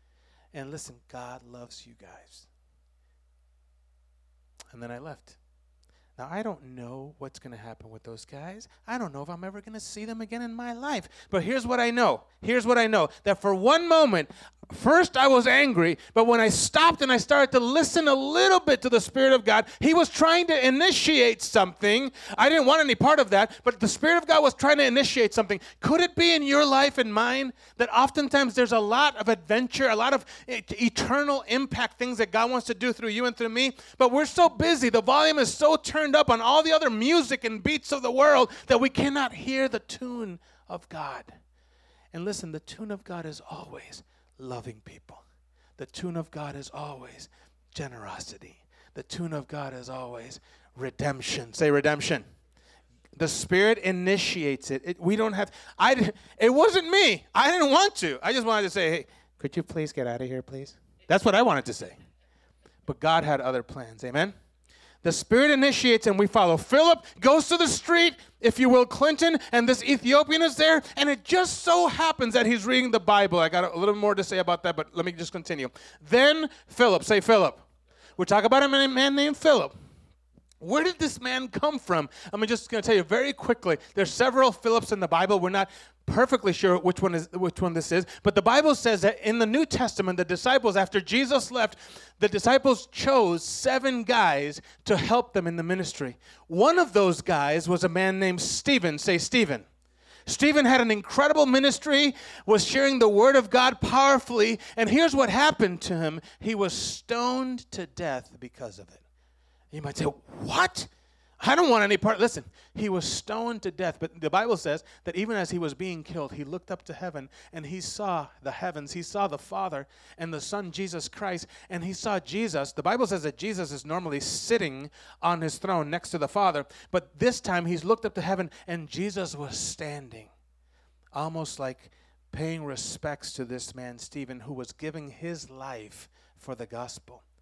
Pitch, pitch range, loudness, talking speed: 205 Hz, 155-255 Hz, -24 LUFS, 200 wpm